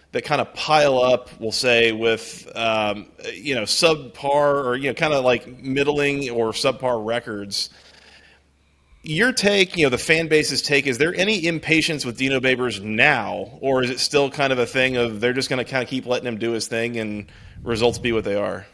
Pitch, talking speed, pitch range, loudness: 125 Hz, 210 wpm, 115-145 Hz, -20 LUFS